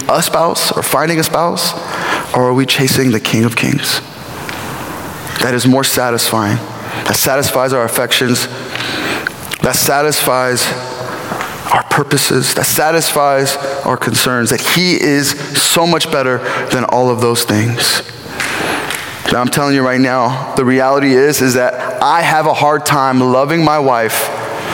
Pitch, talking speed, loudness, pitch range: 130 Hz, 145 wpm, -13 LUFS, 125-145 Hz